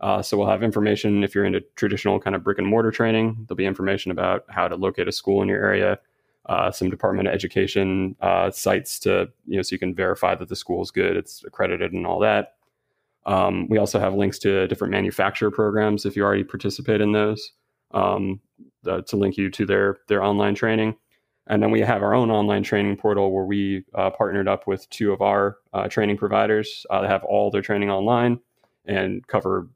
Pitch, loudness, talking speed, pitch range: 100 Hz, -22 LUFS, 215 wpm, 100-105 Hz